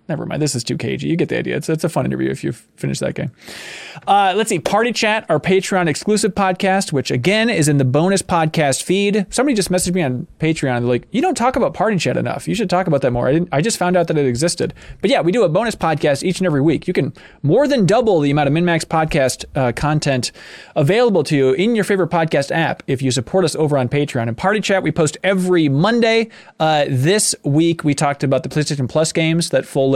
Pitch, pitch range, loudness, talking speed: 160 Hz, 140-190 Hz, -17 LUFS, 250 wpm